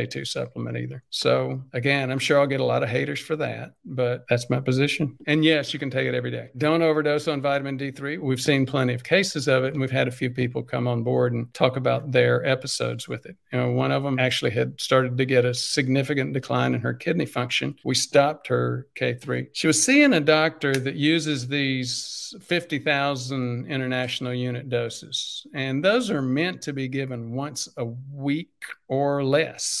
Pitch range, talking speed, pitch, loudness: 125-145 Hz, 200 wpm, 130 Hz, -24 LUFS